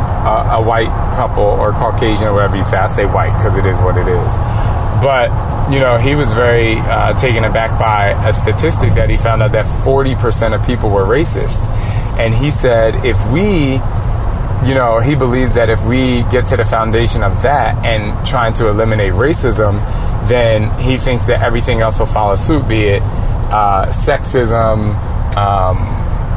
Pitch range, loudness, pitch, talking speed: 105-115 Hz, -13 LUFS, 110 Hz, 180 wpm